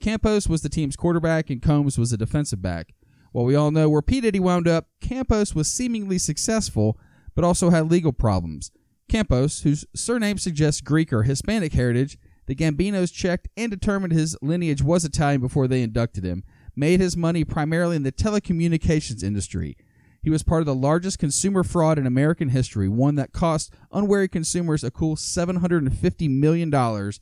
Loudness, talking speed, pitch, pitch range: -22 LUFS, 170 wpm, 155 Hz, 130-175 Hz